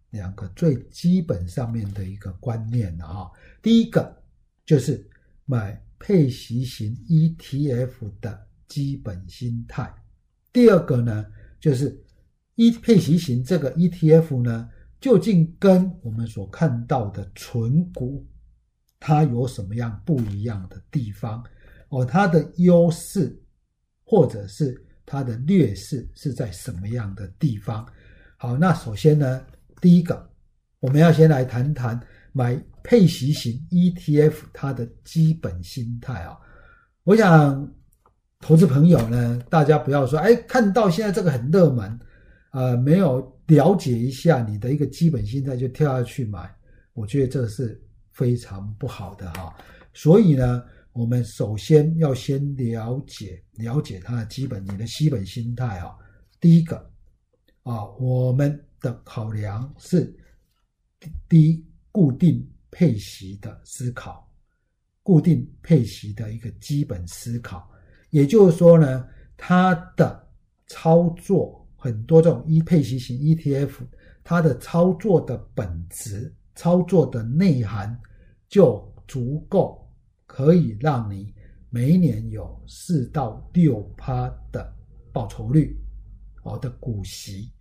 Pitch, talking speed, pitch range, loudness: 125 Hz, 195 characters per minute, 110-155 Hz, -21 LUFS